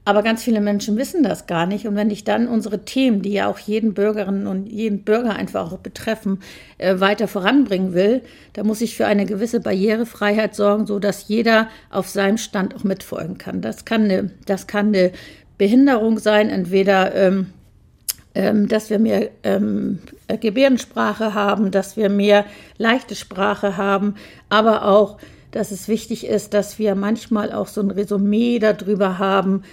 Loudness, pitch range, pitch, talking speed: -19 LUFS, 200-220 Hz, 210 Hz, 165 wpm